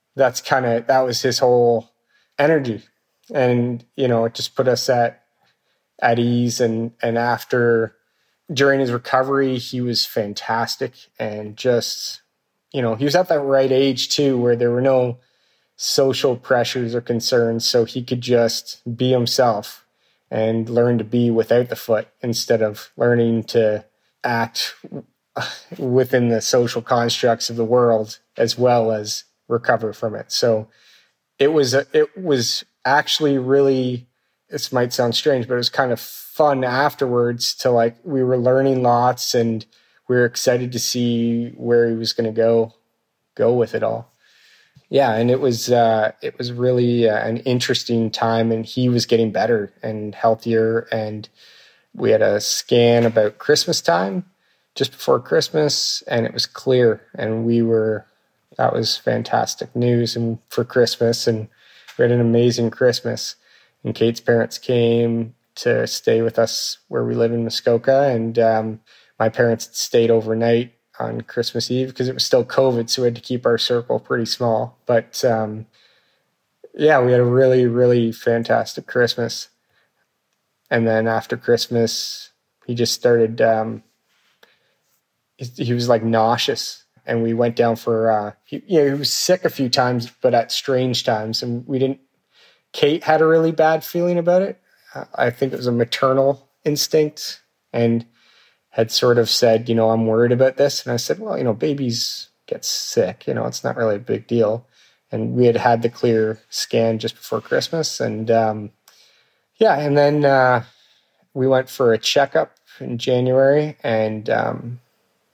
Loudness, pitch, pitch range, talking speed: -19 LUFS, 120 Hz, 115-130 Hz, 160 wpm